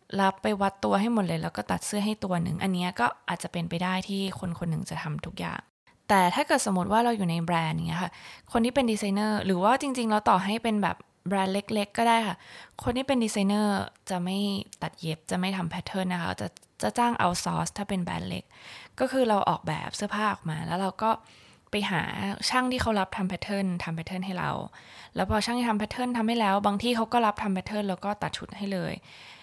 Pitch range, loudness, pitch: 180-215 Hz, -28 LUFS, 200 Hz